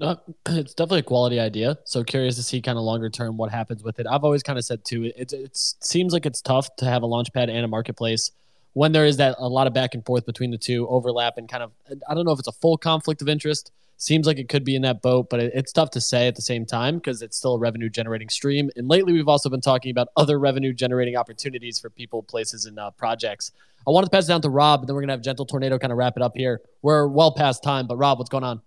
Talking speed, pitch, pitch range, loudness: 290 wpm, 130 Hz, 120-145 Hz, -22 LUFS